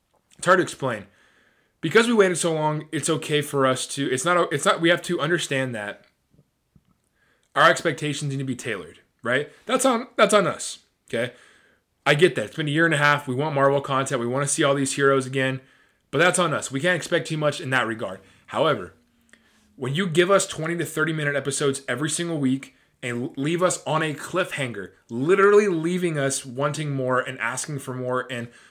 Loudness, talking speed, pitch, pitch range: -23 LUFS, 205 wpm, 145 Hz, 130-170 Hz